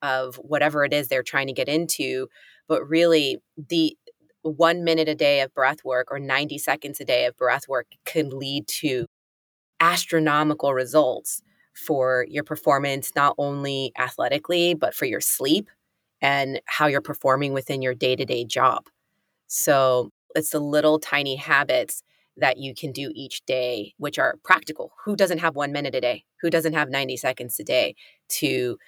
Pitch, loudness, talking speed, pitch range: 140 Hz, -23 LUFS, 170 wpm, 130-155 Hz